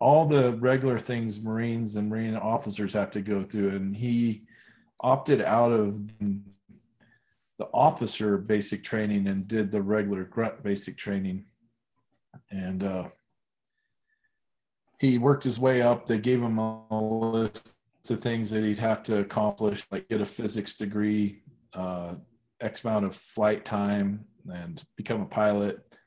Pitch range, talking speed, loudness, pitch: 100-120 Hz, 145 wpm, -28 LUFS, 110 Hz